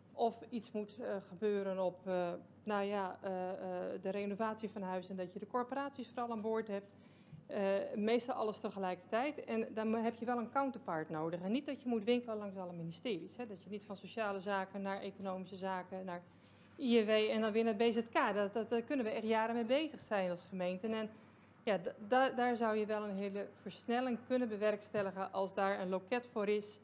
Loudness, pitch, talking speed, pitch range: -39 LUFS, 210 Hz, 195 wpm, 190-230 Hz